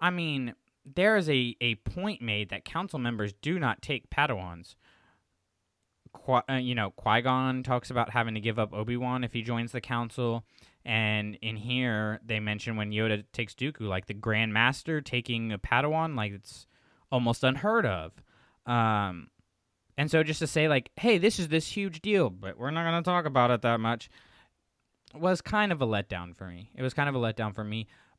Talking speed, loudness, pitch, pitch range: 200 wpm, -29 LUFS, 120 Hz, 105-135 Hz